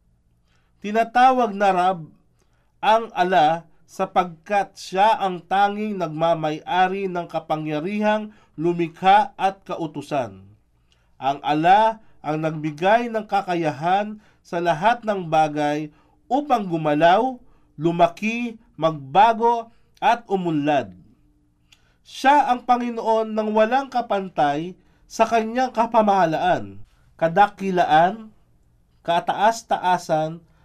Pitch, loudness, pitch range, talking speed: 185 Hz, -21 LUFS, 155-220 Hz, 80 wpm